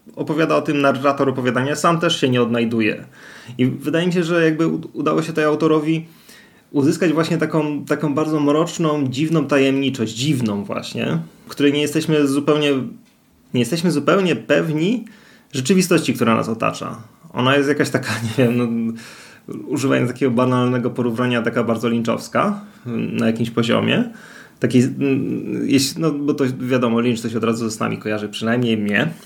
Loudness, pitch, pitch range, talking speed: -19 LUFS, 135 Hz, 120-155 Hz, 150 wpm